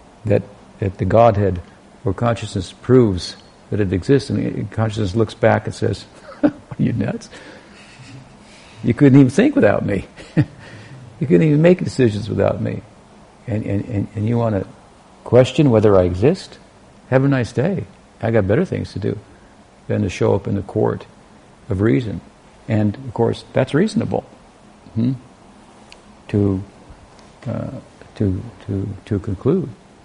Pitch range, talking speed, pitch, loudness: 100-125 Hz, 150 wpm, 110 Hz, -18 LUFS